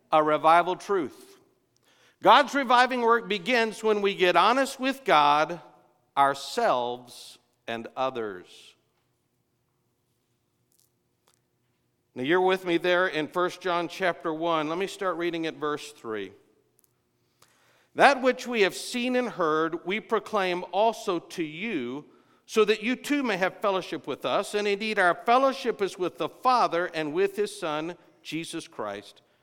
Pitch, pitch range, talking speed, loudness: 180 Hz, 155-220 Hz, 140 wpm, -25 LUFS